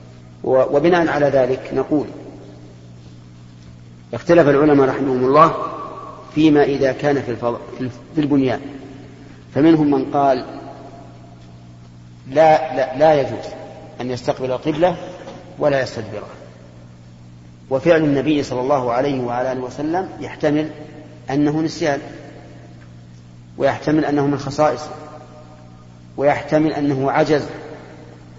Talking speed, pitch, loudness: 95 wpm, 135 Hz, -18 LUFS